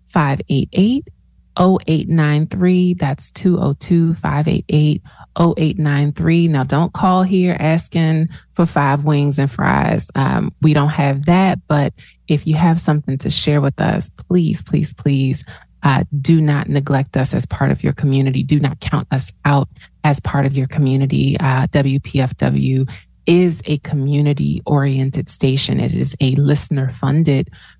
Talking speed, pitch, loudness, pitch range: 140 wpm, 150 Hz, -16 LUFS, 140-165 Hz